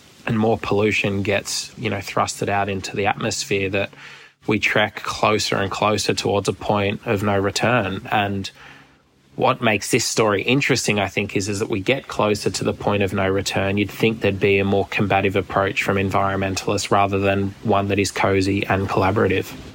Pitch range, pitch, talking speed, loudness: 95-105 Hz, 100 Hz, 185 wpm, -20 LUFS